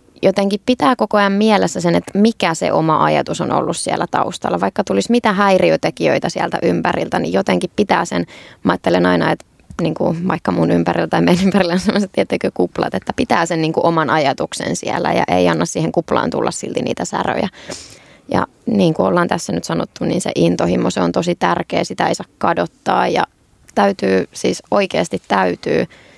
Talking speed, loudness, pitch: 185 wpm, -16 LUFS, 170 Hz